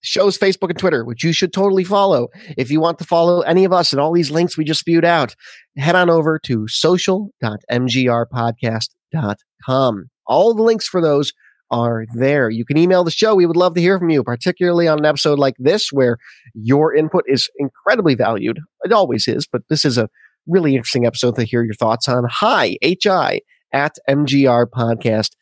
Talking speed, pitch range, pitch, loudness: 190 wpm, 120-175 Hz, 150 Hz, -16 LUFS